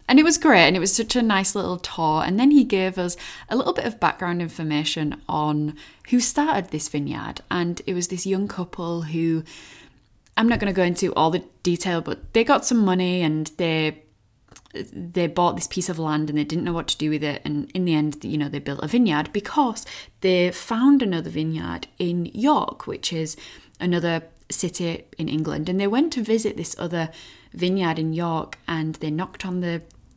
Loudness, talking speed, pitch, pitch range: -22 LUFS, 205 wpm, 175 Hz, 155-195 Hz